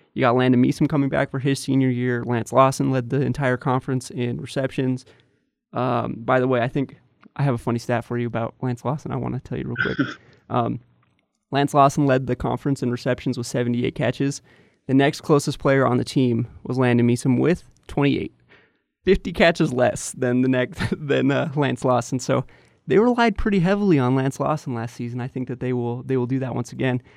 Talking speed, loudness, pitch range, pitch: 210 wpm, -22 LUFS, 125-140 Hz, 130 Hz